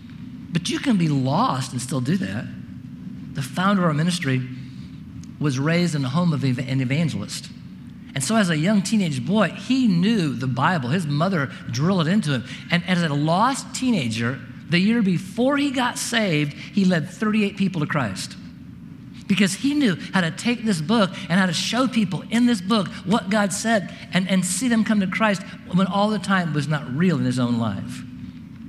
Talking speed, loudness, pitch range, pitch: 195 wpm, -22 LUFS, 150-215 Hz, 185 Hz